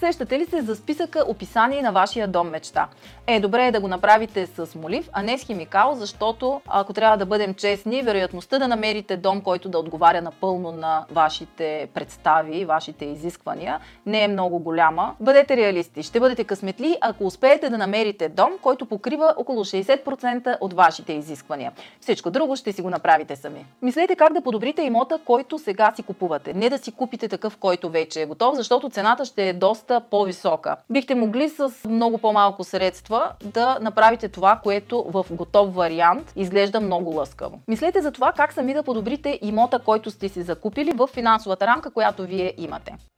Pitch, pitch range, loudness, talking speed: 215 Hz, 185-250 Hz, -22 LUFS, 175 wpm